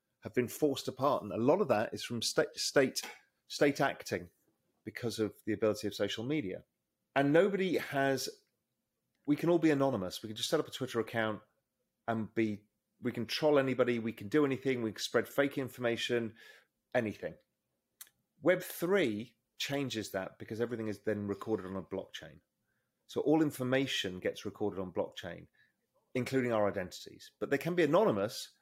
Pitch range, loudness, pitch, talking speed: 110-140 Hz, -34 LUFS, 120 Hz, 170 wpm